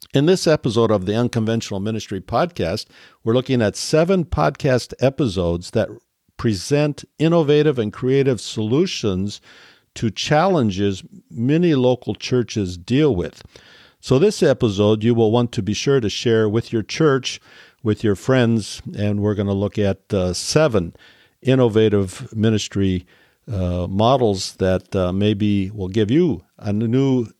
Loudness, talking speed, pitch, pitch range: -19 LUFS, 140 wpm, 115 Hz, 100-135 Hz